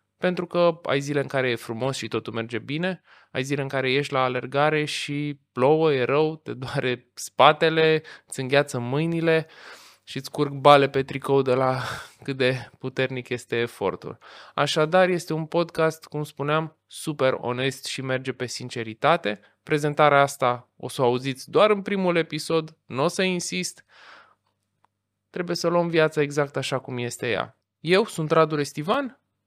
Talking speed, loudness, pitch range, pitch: 165 wpm, -24 LUFS, 130-160 Hz, 140 Hz